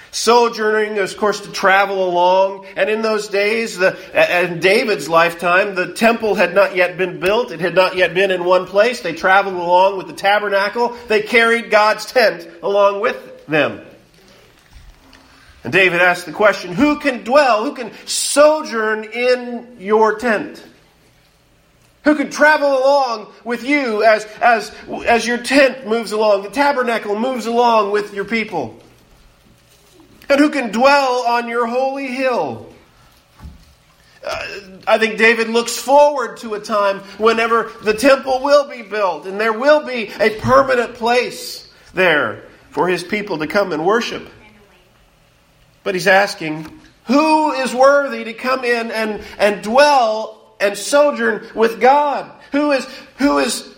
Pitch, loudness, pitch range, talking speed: 225 Hz, -15 LUFS, 200-255 Hz, 150 wpm